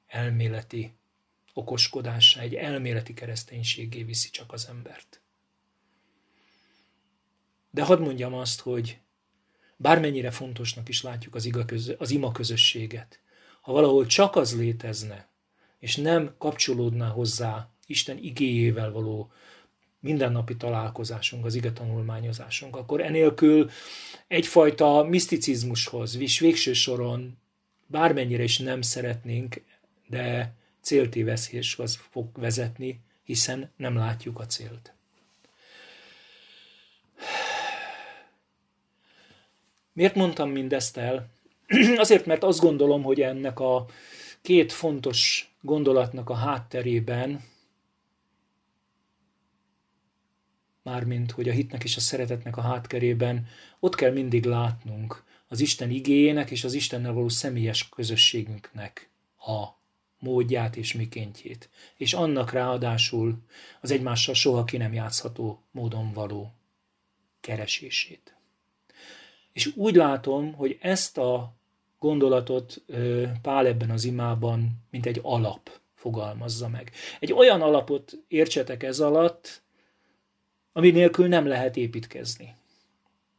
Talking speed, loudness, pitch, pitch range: 100 wpm, -25 LUFS, 125 Hz, 115-140 Hz